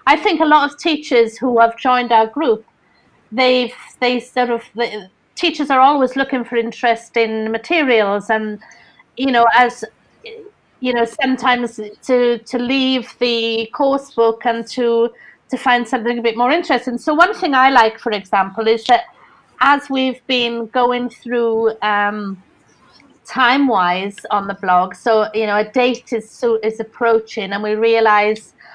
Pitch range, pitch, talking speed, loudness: 220-255 Hz, 240 Hz, 165 wpm, -16 LUFS